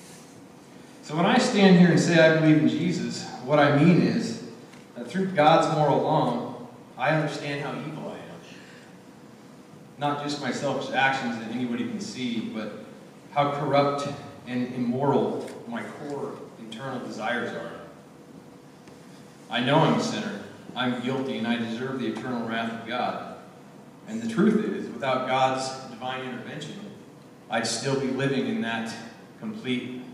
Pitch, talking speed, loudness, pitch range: 145 Hz, 150 wpm, -25 LUFS, 125-170 Hz